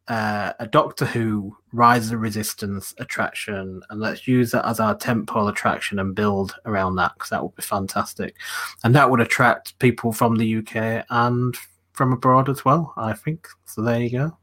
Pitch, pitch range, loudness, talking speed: 115 Hz, 105-125 Hz, -21 LUFS, 185 wpm